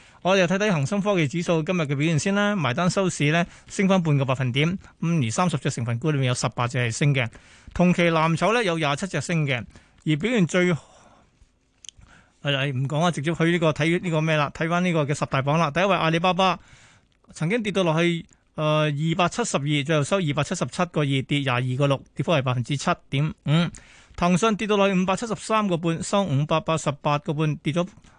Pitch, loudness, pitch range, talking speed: 160 Hz, -23 LUFS, 145-180 Hz, 325 characters per minute